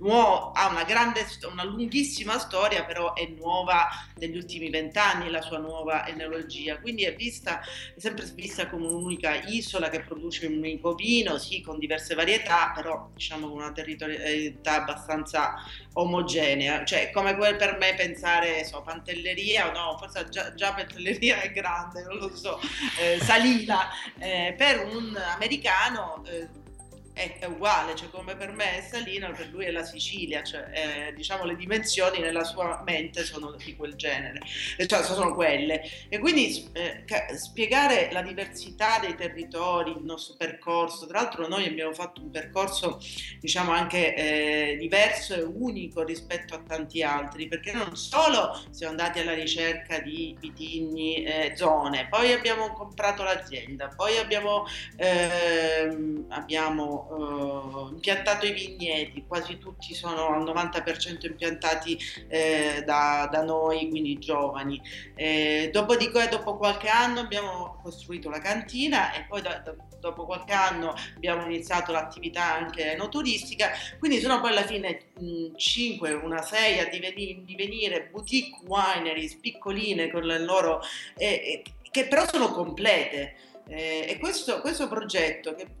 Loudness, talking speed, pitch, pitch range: -27 LUFS, 145 wpm, 170 Hz, 160-200 Hz